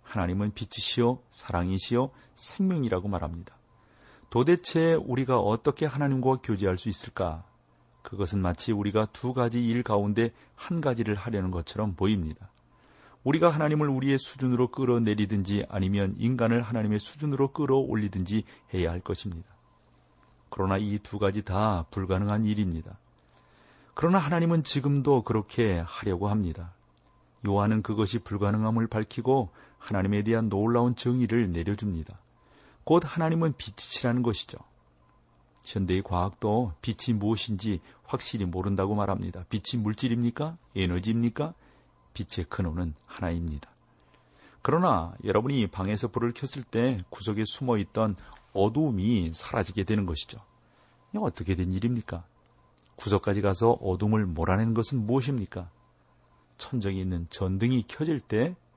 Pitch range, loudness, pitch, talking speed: 95-120 Hz, -28 LUFS, 105 Hz, 325 characters per minute